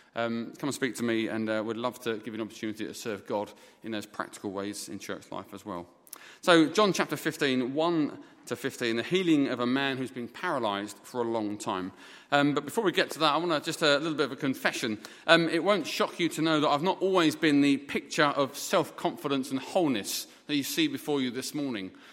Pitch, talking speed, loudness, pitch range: 135 Hz, 245 wpm, -29 LUFS, 115-155 Hz